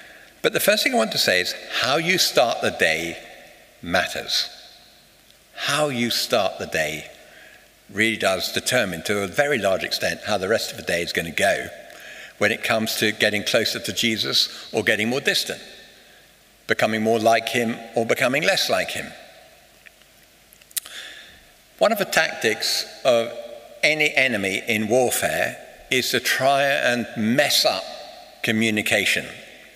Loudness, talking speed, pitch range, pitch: -21 LUFS, 150 wpm, 110-125 Hz, 115 Hz